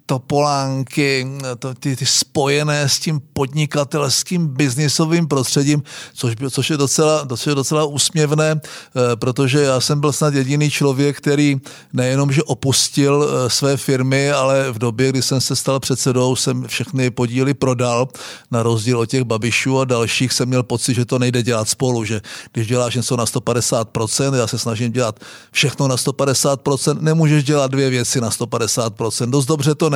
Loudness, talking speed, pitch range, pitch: -17 LUFS, 165 wpm, 125-145 Hz, 135 Hz